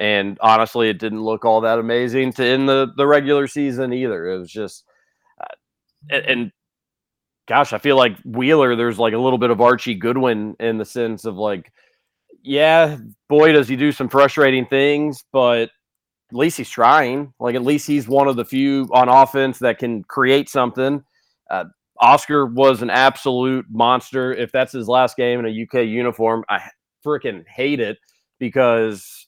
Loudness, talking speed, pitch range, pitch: -17 LUFS, 175 wpm, 115-135 Hz, 130 Hz